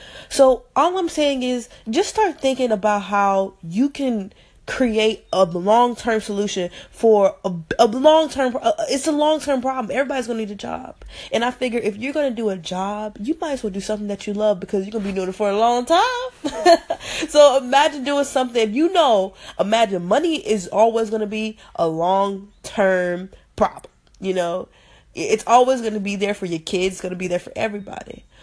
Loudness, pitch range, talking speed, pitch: -20 LUFS, 200-275 Hz, 200 wpm, 225 Hz